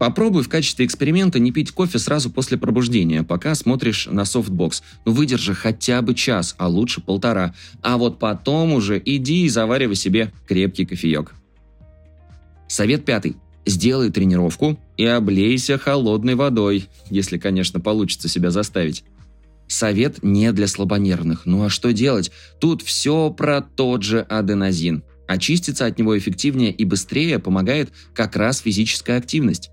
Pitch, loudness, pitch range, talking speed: 105 Hz, -19 LUFS, 90-125 Hz, 140 wpm